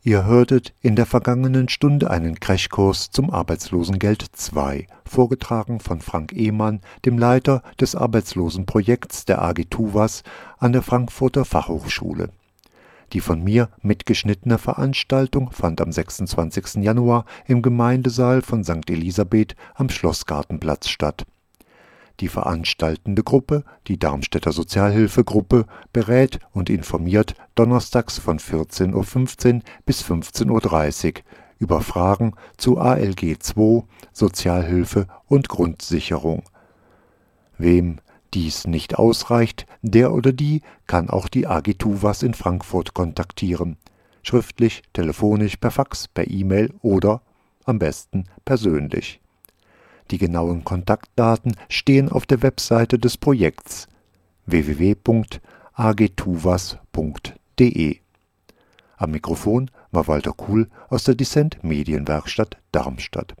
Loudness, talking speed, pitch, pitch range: -20 LUFS, 105 wpm, 105 Hz, 85-120 Hz